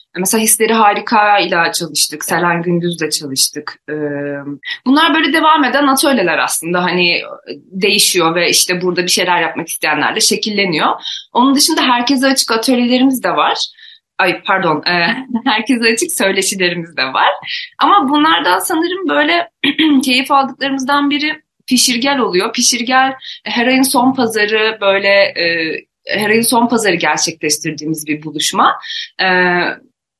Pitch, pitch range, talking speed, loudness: 220 Hz, 175-275 Hz, 125 wpm, -13 LUFS